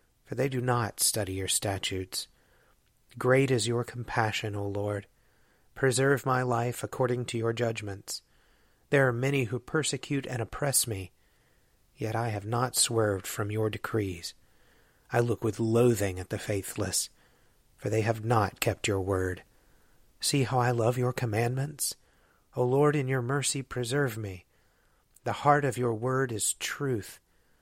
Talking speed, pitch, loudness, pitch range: 150 wpm, 115 Hz, -29 LUFS, 105-130 Hz